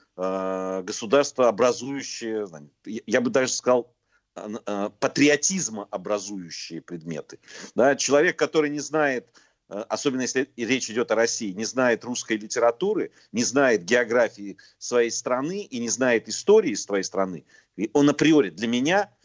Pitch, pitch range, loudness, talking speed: 120 Hz, 105-145 Hz, -24 LUFS, 120 wpm